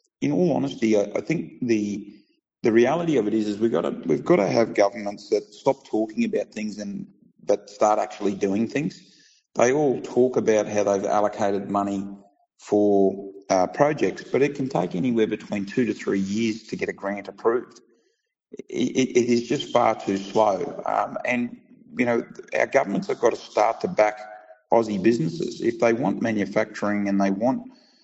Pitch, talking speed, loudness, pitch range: 105 Hz, 180 wpm, -23 LUFS, 100-120 Hz